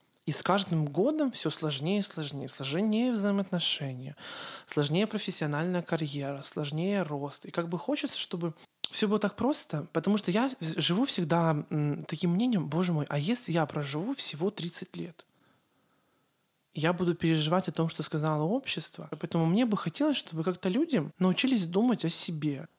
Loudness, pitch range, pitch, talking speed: -30 LUFS, 155-200 Hz, 175 Hz, 155 wpm